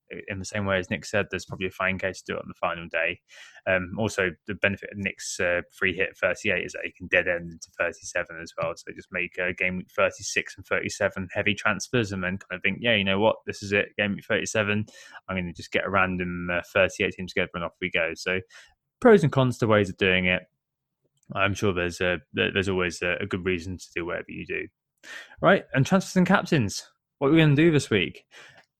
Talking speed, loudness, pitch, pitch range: 245 wpm, -25 LUFS, 95 Hz, 90-110 Hz